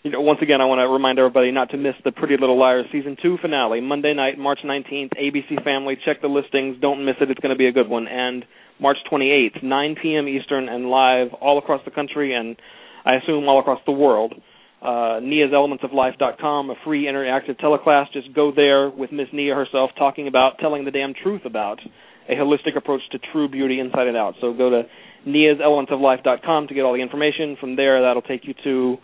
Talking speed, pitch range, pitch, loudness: 230 wpm, 130-145 Hz, 140 Hz, -19 LUFS